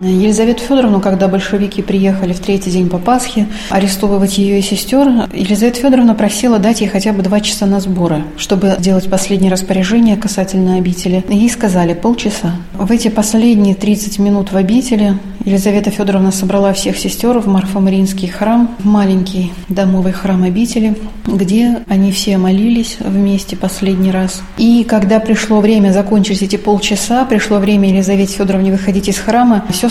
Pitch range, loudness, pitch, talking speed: 190-215 Hz, -12 LUFS, 200 Hz, 155 wpm